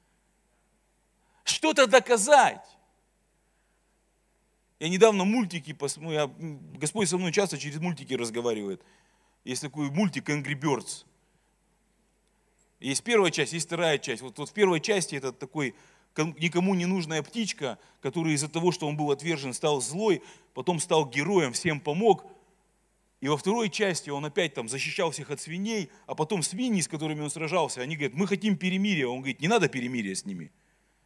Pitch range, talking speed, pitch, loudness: 145-200 Hz, 150 wpm, 165 Hz, -27 LUFS